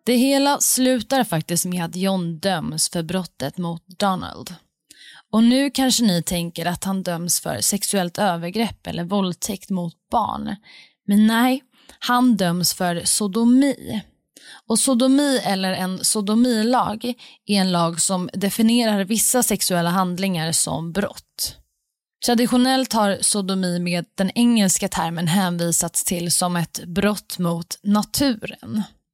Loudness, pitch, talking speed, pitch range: -20 LUFS, 195 Hz, 130 wpm, 175-230 Hz